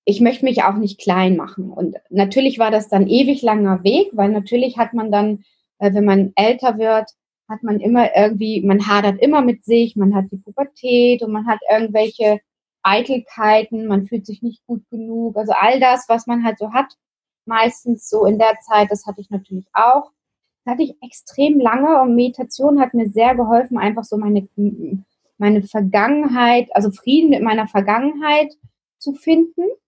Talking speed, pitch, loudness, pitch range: 180 wpm, 225 Hz, -16 LUFS, 205-250 Hz